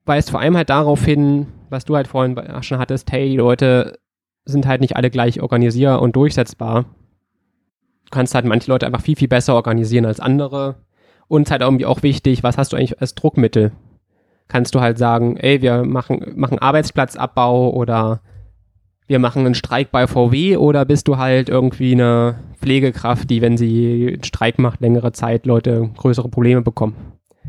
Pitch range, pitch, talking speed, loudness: 120-135 Hz, 125 Hz, 180 wpm, -16 LUFS